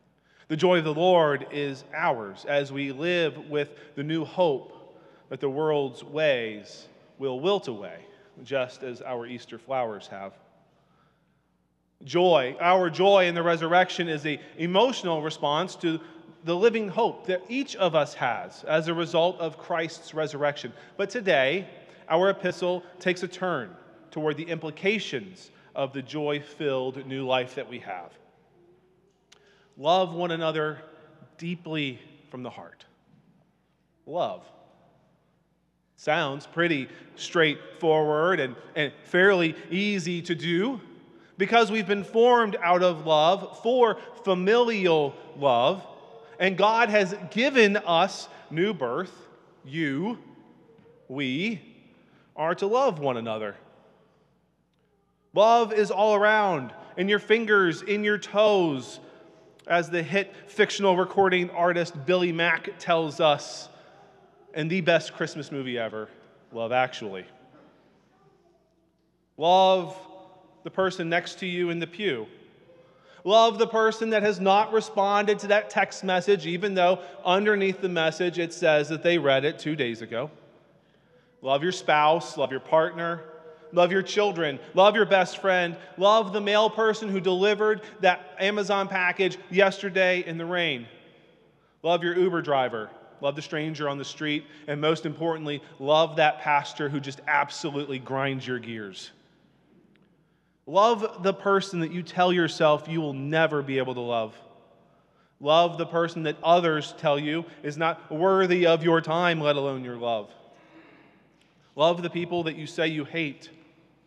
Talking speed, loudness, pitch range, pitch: 135 wpm, -25 LUFS, 150-190 Hz, 170 Hz